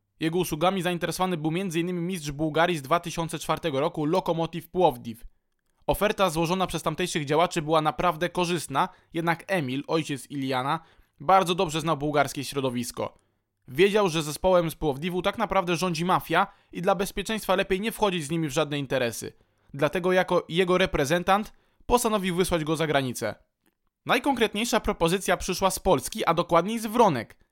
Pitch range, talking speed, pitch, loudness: 155-190 Hz, 145 wpm, 170 Hz, -26 LUFS